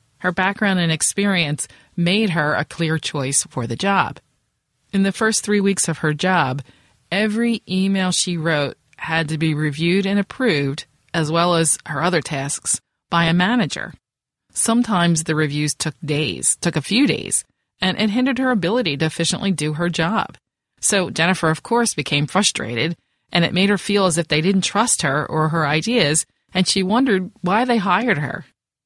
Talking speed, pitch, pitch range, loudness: 175 wpm, 175 Hz, 155-200 Hz, -19 LUFS